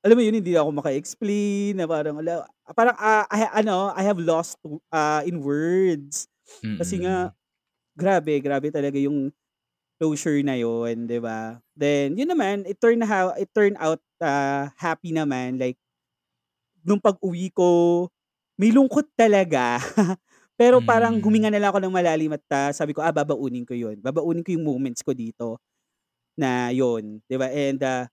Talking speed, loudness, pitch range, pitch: 165 wpm, -23 LUFS, 140-200 Hz, 160 Hz